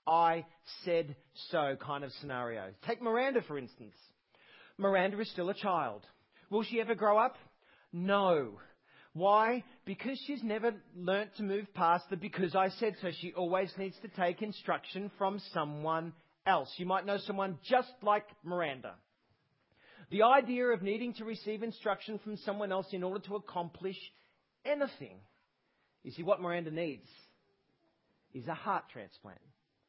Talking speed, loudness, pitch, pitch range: 150 wpm, -34 LUFS, 195 Hz, 170-215 Hz